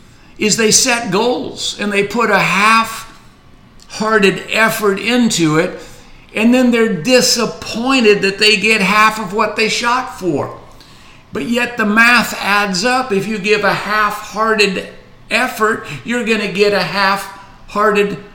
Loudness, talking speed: -13 LUFS, 150 wpm